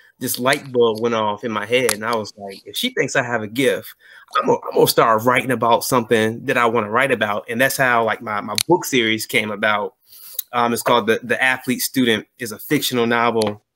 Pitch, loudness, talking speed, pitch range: 120 Hz, -18 LUFS, 235 wpm, 110-130 Hz